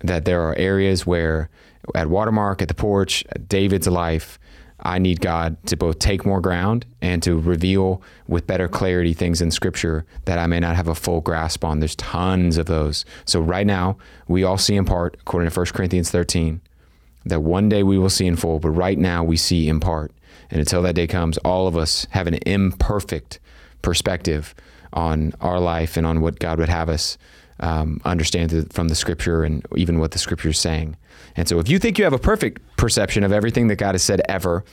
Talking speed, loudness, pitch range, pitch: 215 wpm, -20 LUFS, 80-95 Hz, 85 Hz